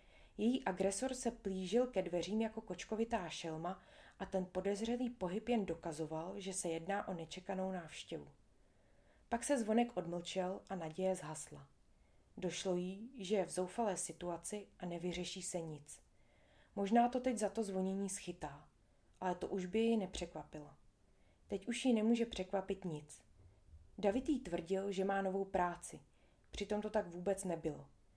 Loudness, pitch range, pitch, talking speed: -40 LUFS, 170-210 Hz, 190 Hz, 145 wpm